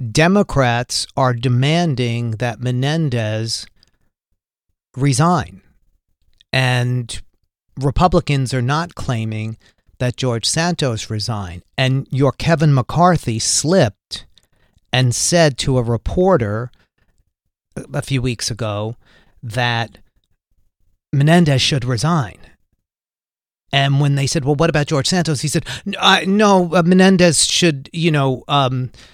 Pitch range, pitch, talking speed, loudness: 115-155 Hz, 130 Hz, 105 wpm, -17 LUFS